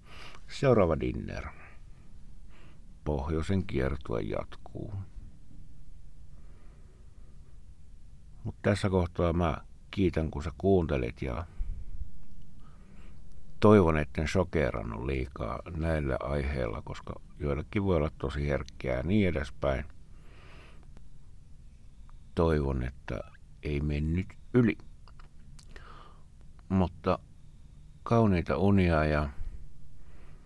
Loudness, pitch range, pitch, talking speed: -30 LUFS, 70-90 Hz, 75 Hz, 75 wpm